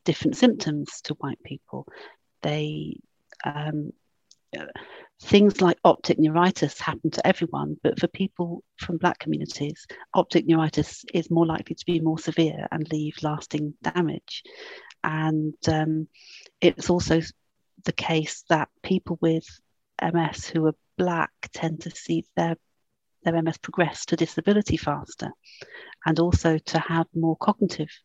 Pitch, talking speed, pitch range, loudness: 165 Hz, 135 wpm, 155-175 Hz, -25 LUFS